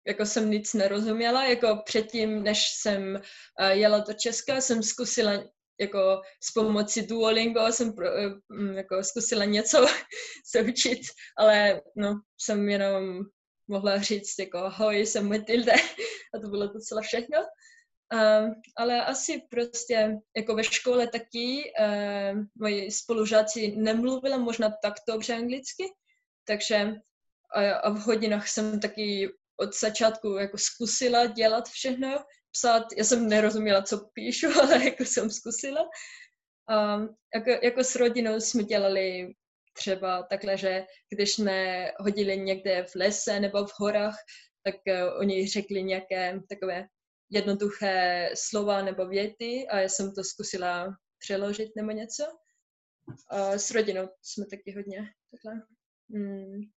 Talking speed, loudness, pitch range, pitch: 130 wpm, -27 LUFS, 200-235 Hz, 215 Hz